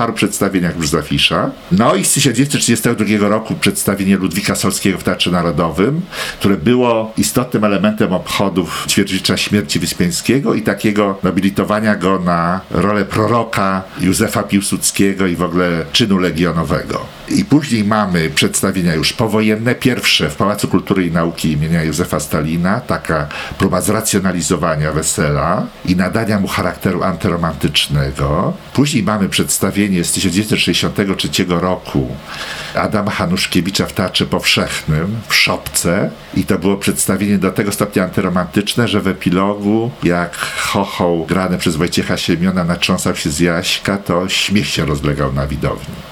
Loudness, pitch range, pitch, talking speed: -15 LUFS, 85-105 Hz, 95 Hz, 130 wpm